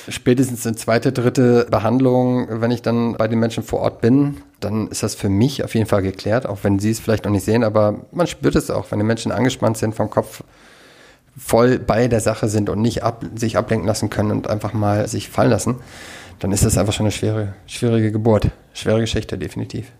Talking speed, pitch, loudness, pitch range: 220 wpm, 110 Hz, -19 LUFS, 105-120 Hz